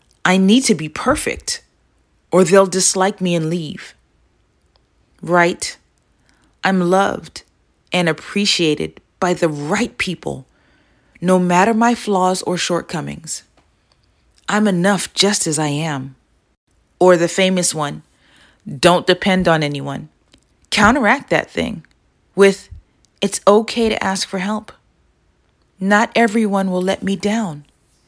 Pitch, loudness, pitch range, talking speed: 185 Hz, -16 LUFS, 155-195 Hz, 120 wpm